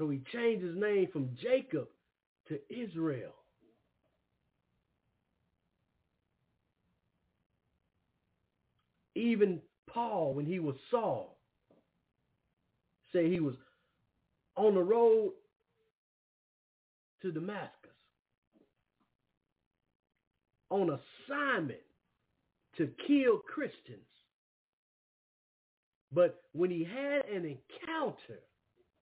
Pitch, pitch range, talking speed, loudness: 185 Hz, 150-250 Hz, 70 wpm, -34 LUFS